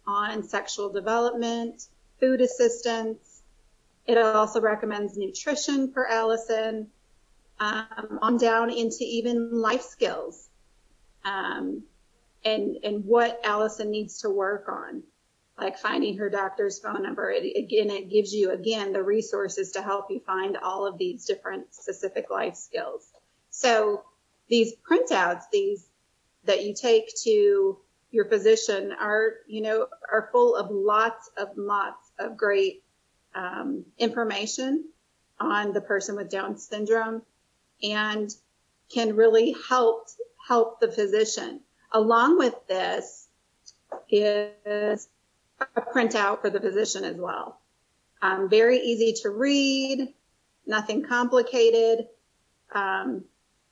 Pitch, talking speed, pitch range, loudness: 225 Hz, 120 wpm, 210-265 Hz, -25 LUFS